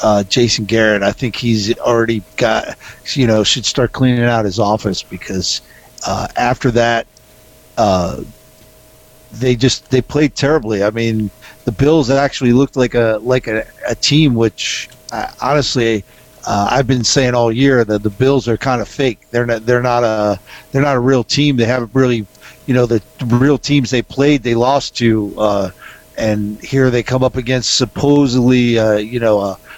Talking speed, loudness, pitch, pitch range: 180 wpm, -14 LUFS, 120 Hz, 110-130 Hz